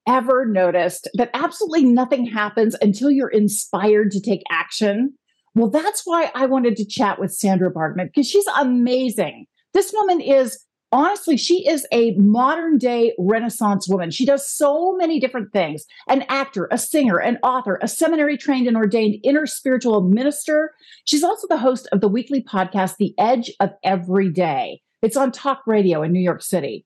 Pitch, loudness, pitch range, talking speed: 245 Hz, -19 LUFS, 205-285 Hz, 170 wpm